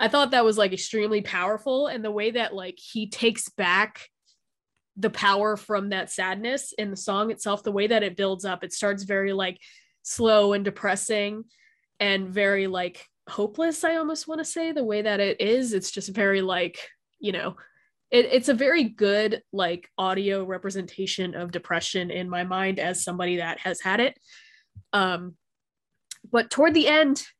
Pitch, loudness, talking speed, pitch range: 205 Hz, -25 LUFS, 175 wpm, 190-230 Hz